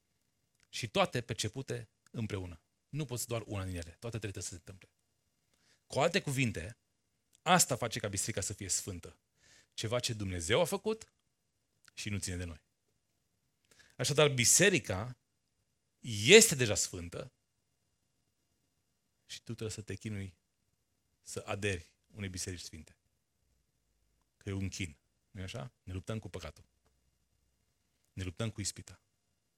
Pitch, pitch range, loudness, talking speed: 105 Hz, 95-120 Hz, -32 LUFS, 130 wpm